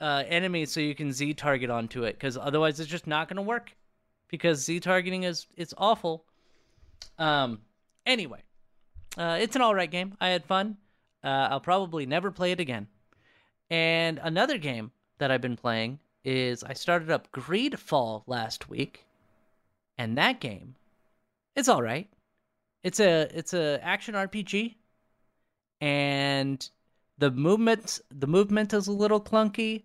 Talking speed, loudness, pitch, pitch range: 155 wpm, -28 LUFS, 160 Hz, 135-185 Hz